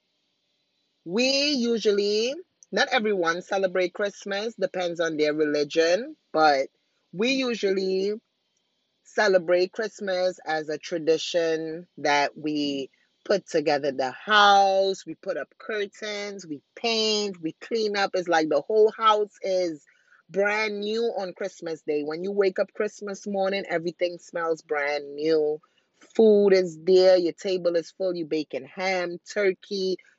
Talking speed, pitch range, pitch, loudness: 130 wpm, 160-205 Hz, 185 Hz, -25 LUFS